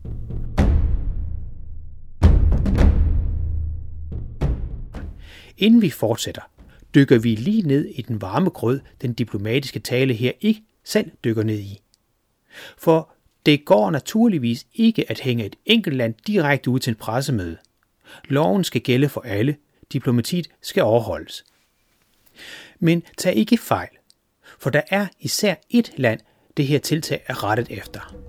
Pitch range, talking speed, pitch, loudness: 95-155 Hz, 125 wpm, 125 Hz, -21 LUFS